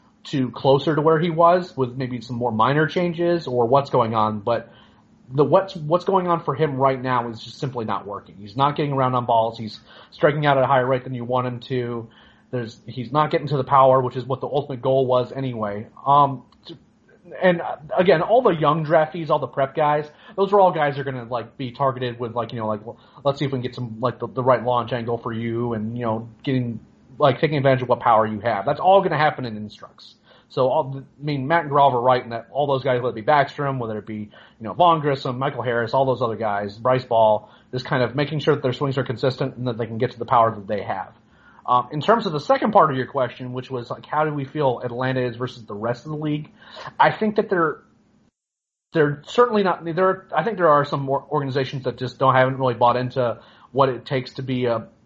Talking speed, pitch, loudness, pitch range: 255 wpm, 130 Hz, -21 LUFS, 120-150 Hz